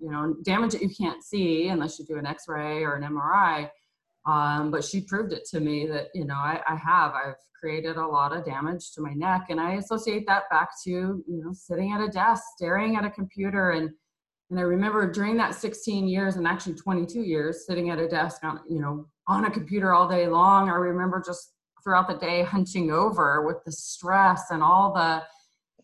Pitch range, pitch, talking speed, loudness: 160-195 Hz, 175 Hz, 215 wpm, -26 LUFS